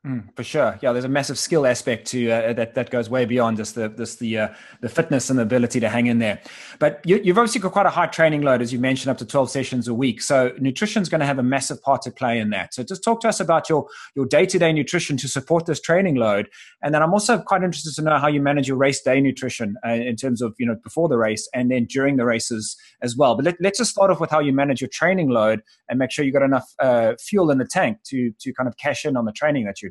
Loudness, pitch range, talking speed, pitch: -21 LUFS, 120-160 Hz, 290 wpm, 135 Hz